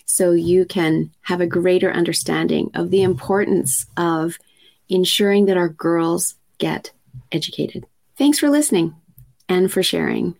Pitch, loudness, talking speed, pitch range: 175 Hz, -18 LUFS, 135 wpm, 165-190 Hz